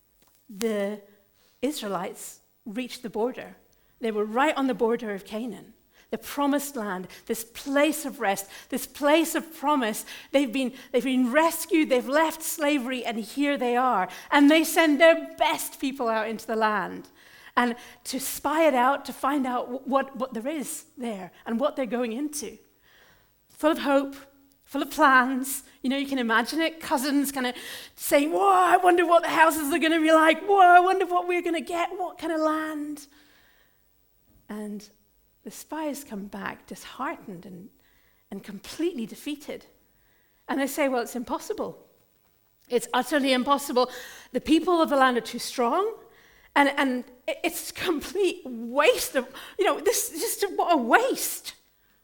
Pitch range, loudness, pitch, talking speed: 245-315 Hz, -25 LUFS, 275 Hz, 165 wpm